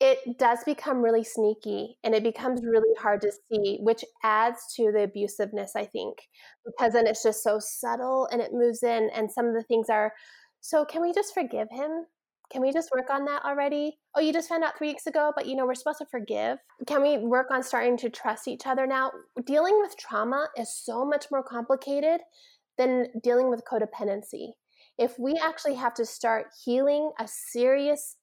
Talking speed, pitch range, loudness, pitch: 200 wpm, 225-290 Hz, -27 LUFS, 255 Hz